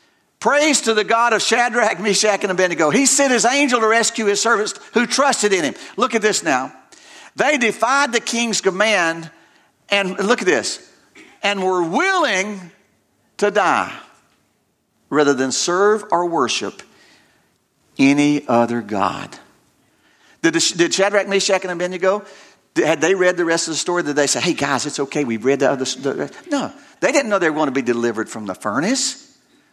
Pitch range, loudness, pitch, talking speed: 165-235 Hz, -17 LUFS, 200 Hz, 170 wpm